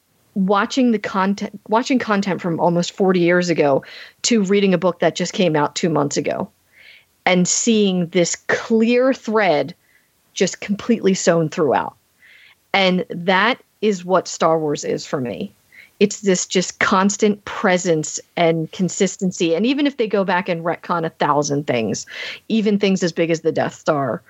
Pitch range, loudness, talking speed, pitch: 170-210 Hz, -18 LUFS, 160 wpm, 185 Hz